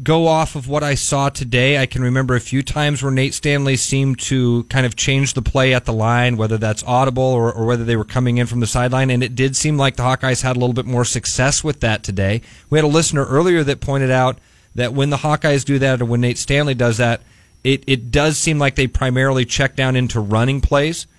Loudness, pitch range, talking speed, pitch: -17 LUFS, 120-140 Hz, 245 wpm, 130 Hz